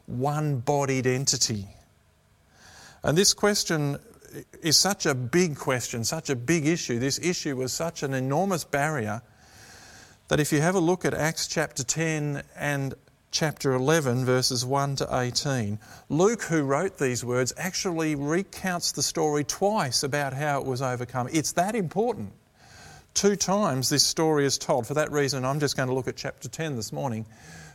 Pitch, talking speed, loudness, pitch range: 145 Hz, 165 wpm, -26 LUFS, 130-165 Hz